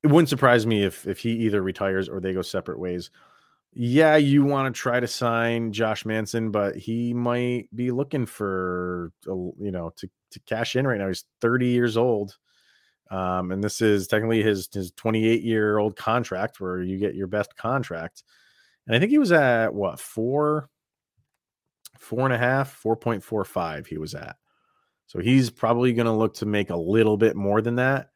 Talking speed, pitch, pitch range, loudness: 190 wpm, 110 Hz, 95-120 Hz, -24 LUFS